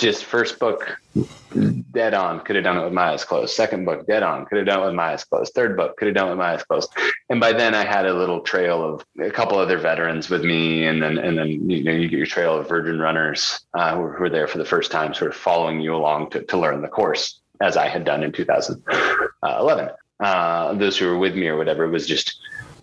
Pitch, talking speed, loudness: 85 Hz, 260 wpm, -21 LUFS